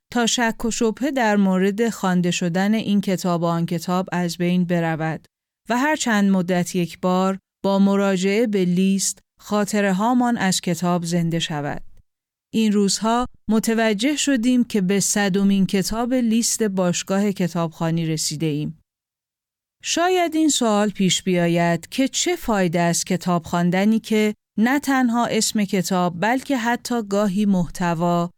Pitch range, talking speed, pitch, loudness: 175-225 Hz, 135 wpm, 195 Hz, -20 LUFS